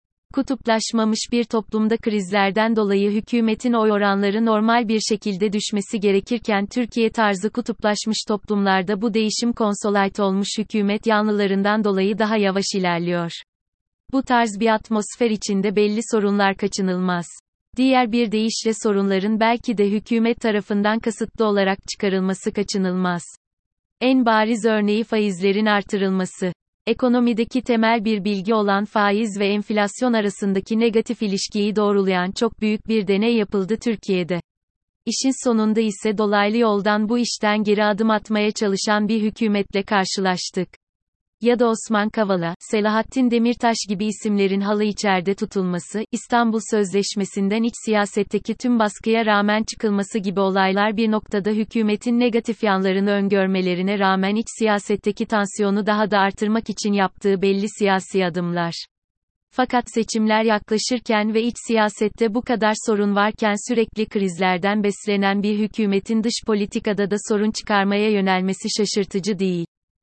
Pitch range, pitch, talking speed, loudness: 200-225 Hz, 210 Hz, 125 wpm, -20 LUFS